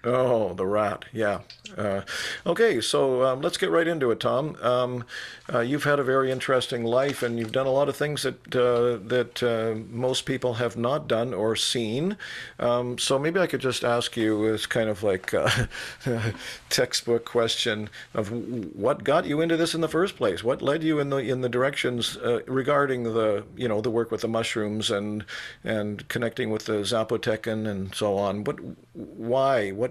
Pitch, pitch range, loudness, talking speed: 120 Hz, 110-130 Hz, -26 LUFS, 190 wpm